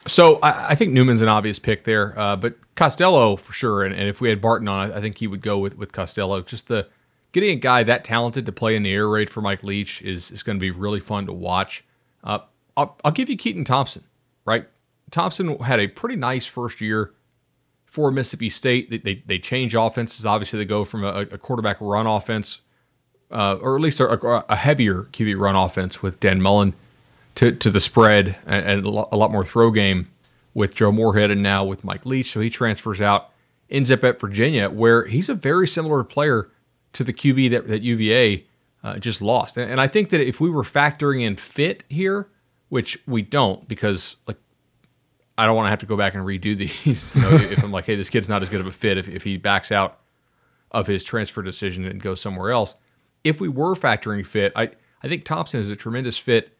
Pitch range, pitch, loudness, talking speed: 100-125 Hz, 110 Hz, -20 LUFS, 225 wpm